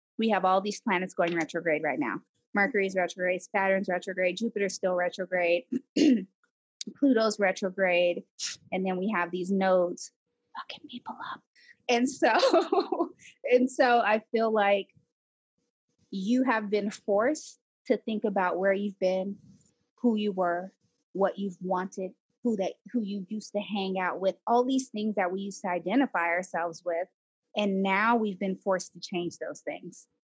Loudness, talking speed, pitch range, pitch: -28 LUFS, 155 wpm, 185-225 Hz, 195 Hz